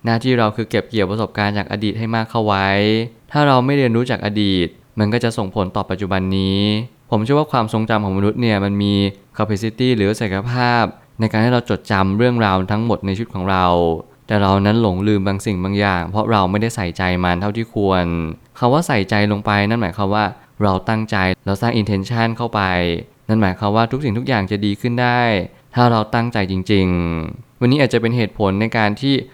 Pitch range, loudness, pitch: 100-115 Hz, -18 LUFS, 105 Hz